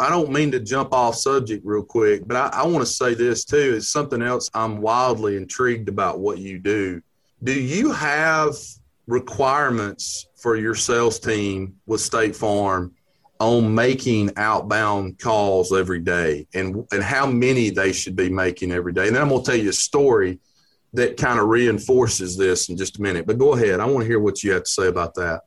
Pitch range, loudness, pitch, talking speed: 95-125 Hz, -20 LUFS, 110 Hz, 205 wpm